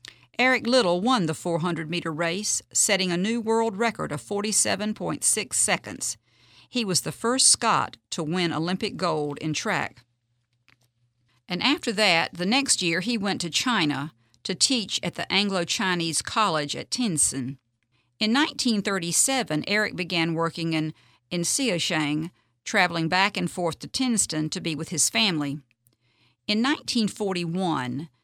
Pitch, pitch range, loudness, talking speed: 175 Hz, 150-215 Hz, -24 LUFS, 140 wpm